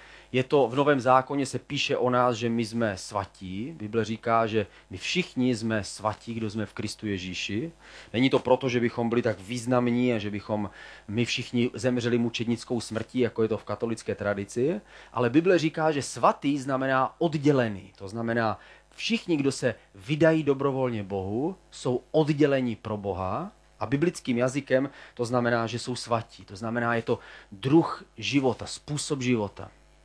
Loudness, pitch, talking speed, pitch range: -27 LUFS, 120 Hz, 165 wpm, 110-135 Hz